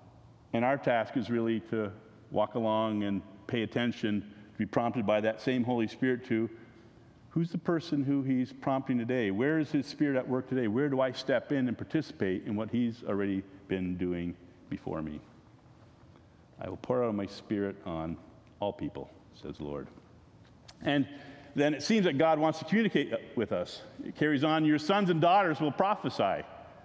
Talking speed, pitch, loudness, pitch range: 185 wpm, 120 Hz, -31 LUFS, 105-140 Hz